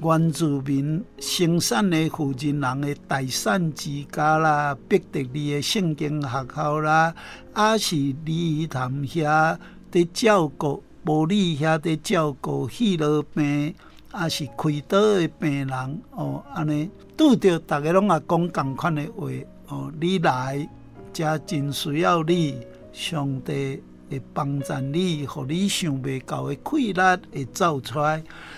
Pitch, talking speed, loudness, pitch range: 155 Hz, 190 characters per minute, -23 LUFS, 140-170 Hz